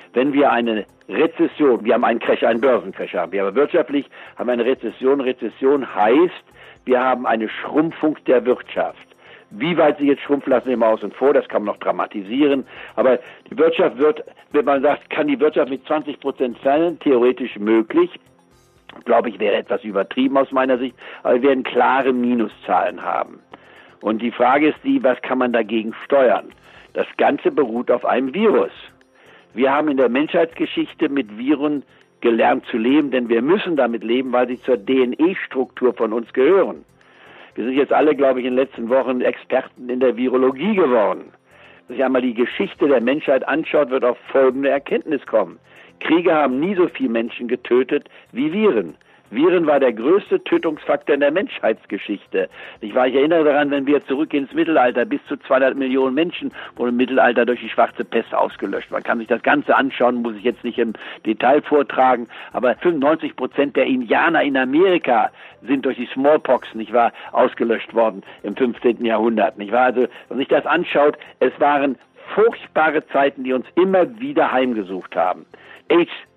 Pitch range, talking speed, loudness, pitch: 120-155 Hz, 180 wpm, -18 LUFS, 130 Hz